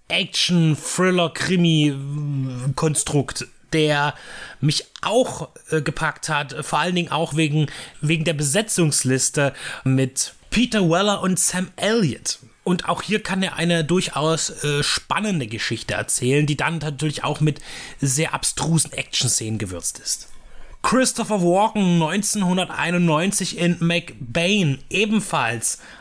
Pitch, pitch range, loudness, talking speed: 160 Hz, 145-180 Hz, -20 LUFS, 110 wpm